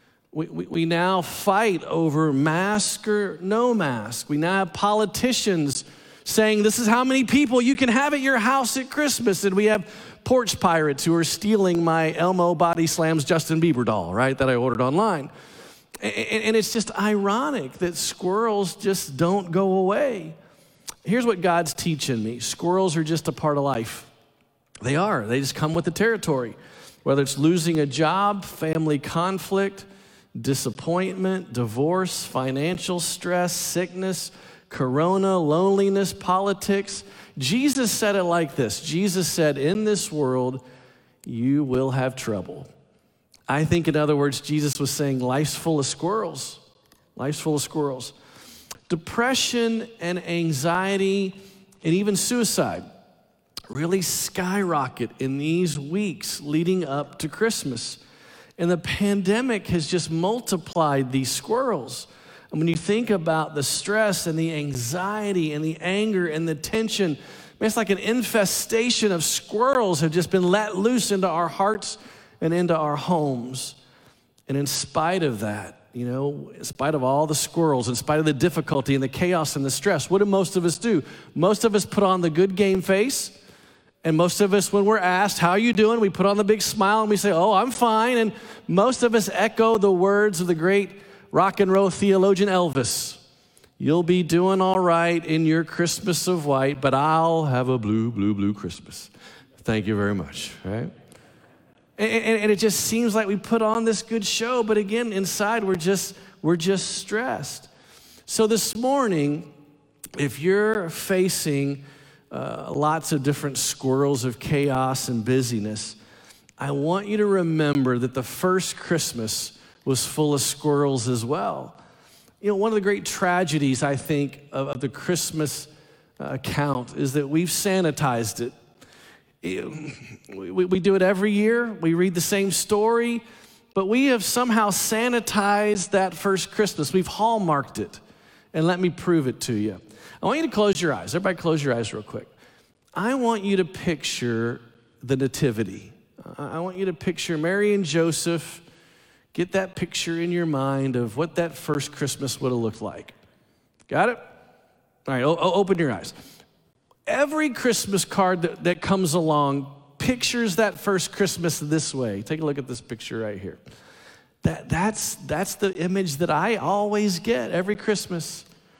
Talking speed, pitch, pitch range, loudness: 165 wpm, 175 Hz, 145-200 Hz, -23 LUFS